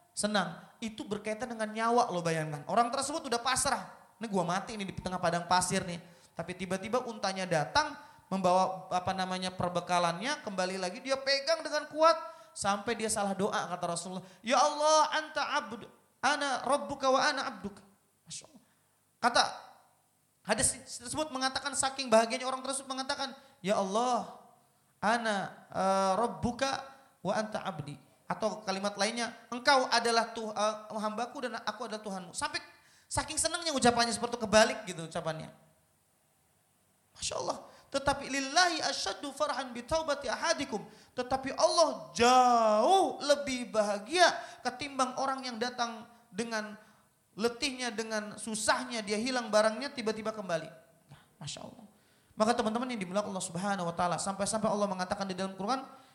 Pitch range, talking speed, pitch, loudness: 195-270 Hz, 140 wpm, 230 Hz, -31 LUFS